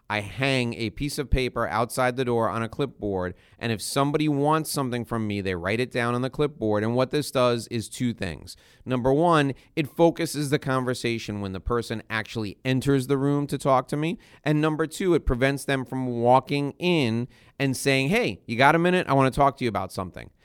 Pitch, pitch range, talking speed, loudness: 130 Hz, 115-140 Hz, 215 wpm, -25 LUFS